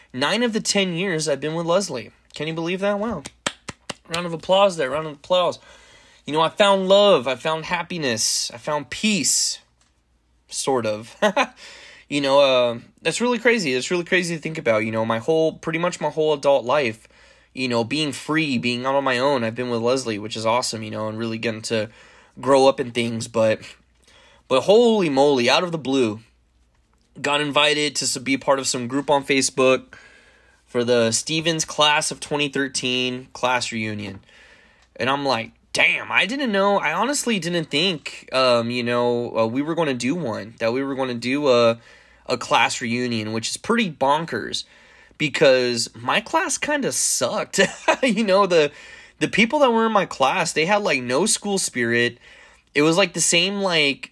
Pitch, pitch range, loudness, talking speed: 140 Hz, 120-180 Hz, -20 LUFS, 185 wpm